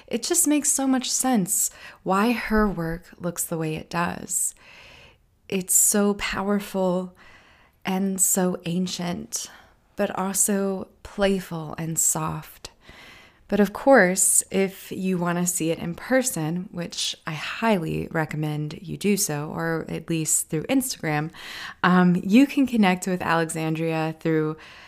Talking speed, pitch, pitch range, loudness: 135 wpm, 185 Hz, 165-205 Hz, -23 LUFS